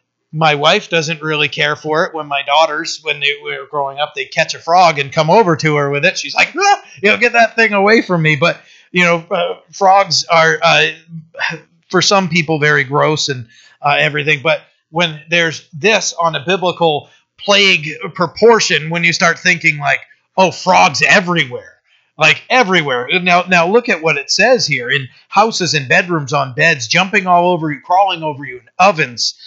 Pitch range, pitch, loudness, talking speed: 150-185 Hz, 165 Hz, -13 LUFS, 190 wpm